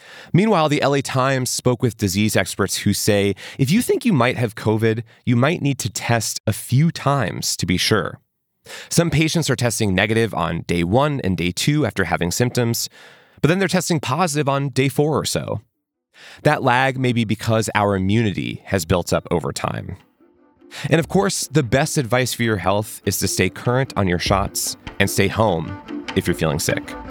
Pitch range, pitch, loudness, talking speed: 100-145 Hz, 120 Hz, -19 LUFS, 195 wpm